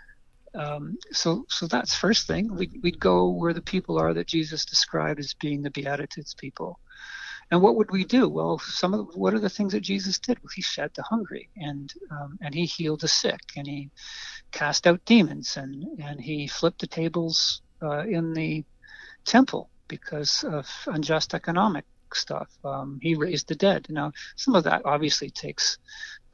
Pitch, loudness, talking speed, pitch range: 165 Hz, -25 LUFS, 180 wpm, 145-210 Hz